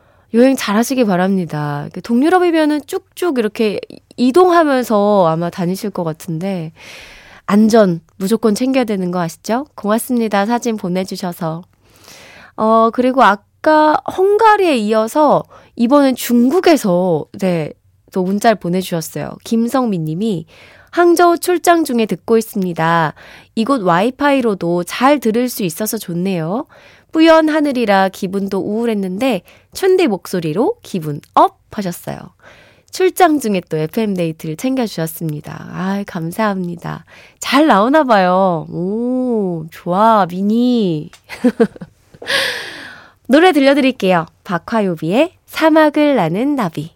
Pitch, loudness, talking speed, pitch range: 220 Hz, -15 LUFS, 270 characters per minute, 180-265 Hz